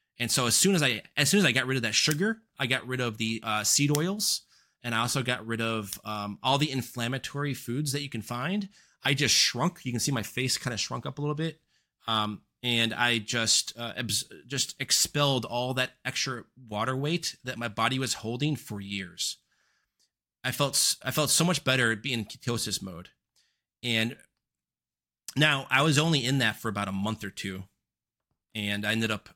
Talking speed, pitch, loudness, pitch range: 205 wpm, 125 Hz, -27 LUFS, 110-140 Hz